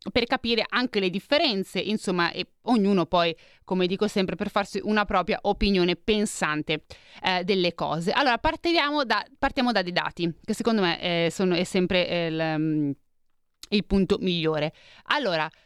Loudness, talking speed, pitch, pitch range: -25 LUFS, 155 wpm, 190 Hz, 175-215 Hz